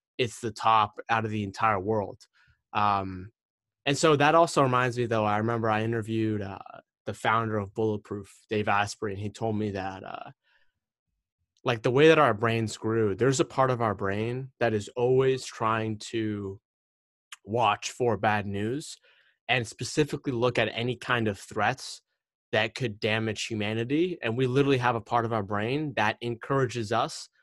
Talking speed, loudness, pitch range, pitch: 175 wpm, -27 LUFS, 105-125 Hz, 110 Hz